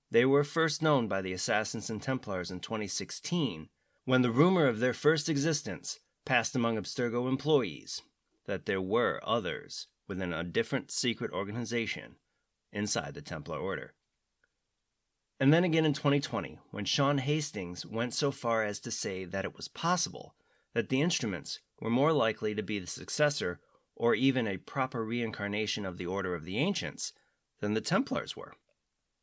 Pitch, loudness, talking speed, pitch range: 120 Hz, -32 LUFS, 160 wpm, 105-140 Hz